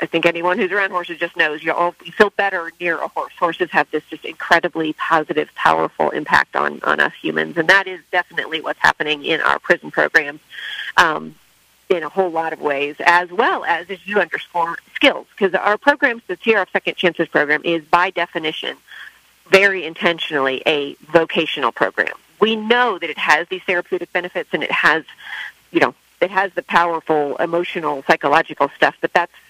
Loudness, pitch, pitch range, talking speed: -18 LUFS, 170 Hz, 155-185 Hz, 180 wpm